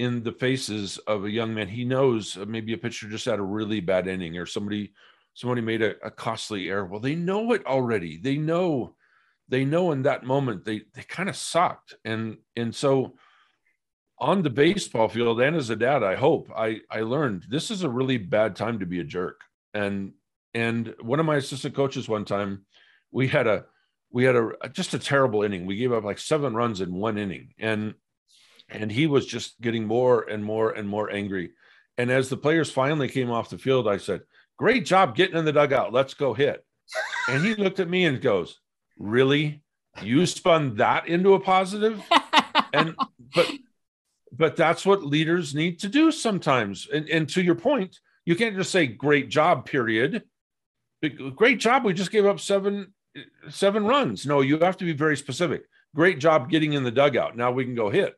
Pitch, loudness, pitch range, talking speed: 135 Hz, -24 LUFS, 110-165 Hz, 200 wpm